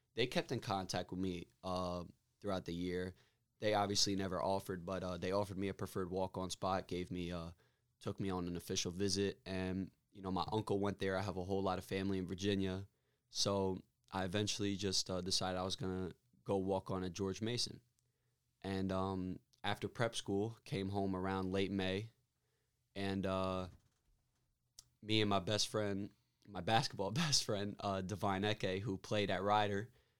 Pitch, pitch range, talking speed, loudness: 95 Hz, 95-105 Hz, 185 wpm, -39 LUFS